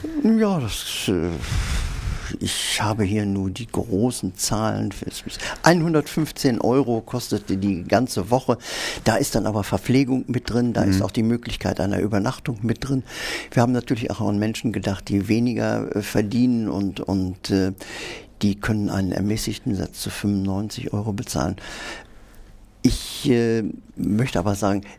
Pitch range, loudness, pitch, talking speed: 100-120 Hz, -23 LUFS, 105 Hz, 135 wpm